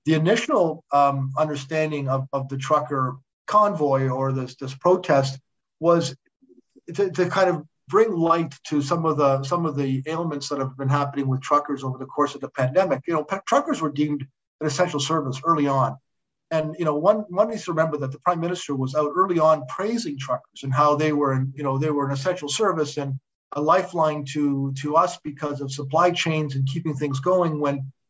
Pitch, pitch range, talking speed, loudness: 150 Hz, 135-165 Hz, 205 wpm, -23 LUFS